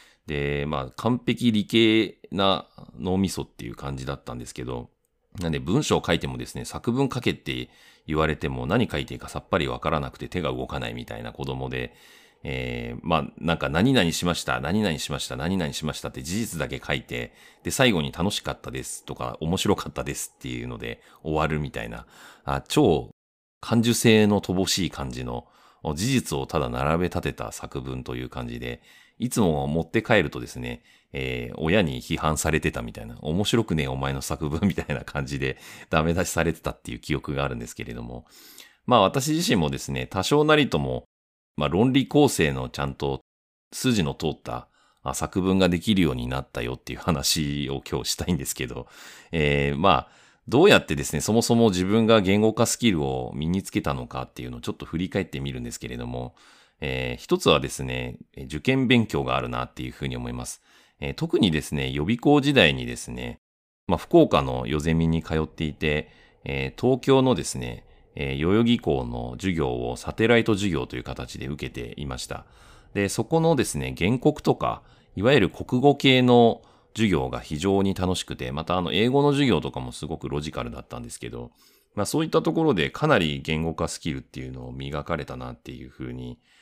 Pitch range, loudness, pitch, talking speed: 65-95 Hz, -25 LUFS, 75 Hz, 380 characters per minute